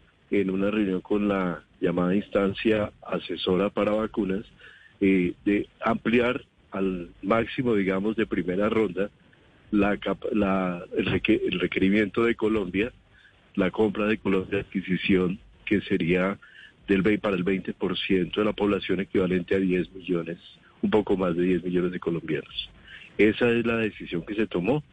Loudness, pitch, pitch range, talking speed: -26 LUFS, 100 Hz, 95-105 Hz, 150 wpm